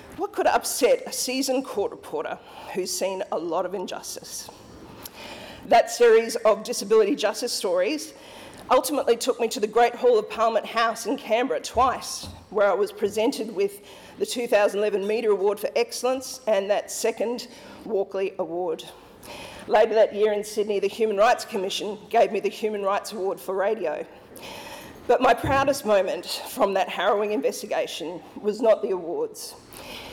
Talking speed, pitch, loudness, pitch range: 155 wpm, 230 Hz, -24 LUFS, 210-280 Hz